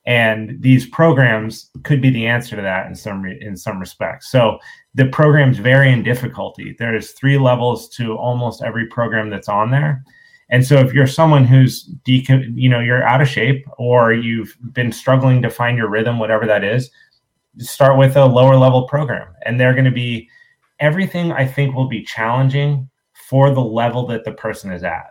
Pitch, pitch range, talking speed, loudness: 125 Hz, 115-135 Hz, 195 wpm, -15 LUFS